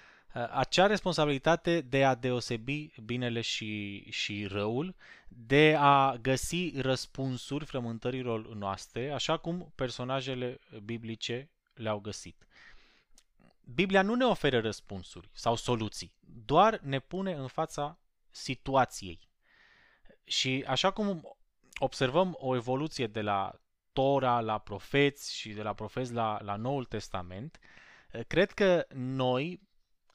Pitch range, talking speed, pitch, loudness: 115-150 Hz, 110 wpm, 130 Hz, -31 LUFS